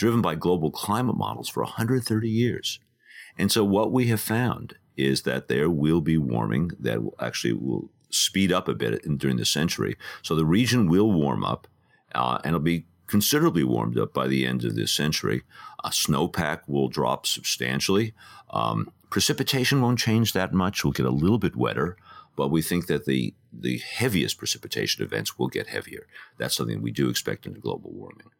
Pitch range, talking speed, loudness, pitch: 70-115 Hz, 190 wpm, -25 LUFS, 90 Hz